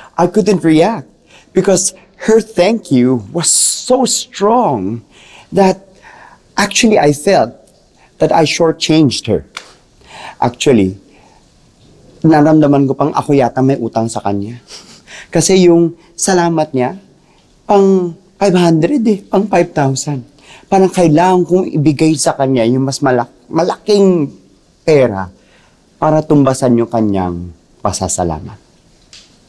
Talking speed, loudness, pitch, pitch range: 110 wpm, -12 LUFS, 160 Hz, 130-190 Hz